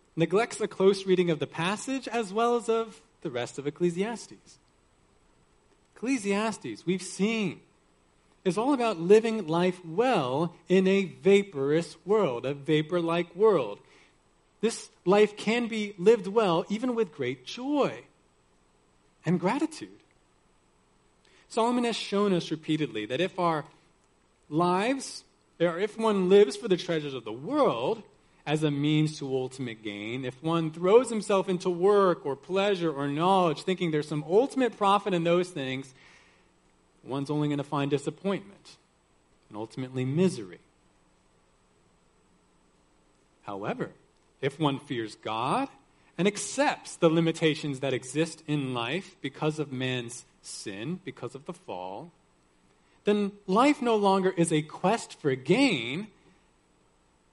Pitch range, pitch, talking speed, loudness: 135-200 Hz, 170 Hz, 130 wpm, -28 LUFS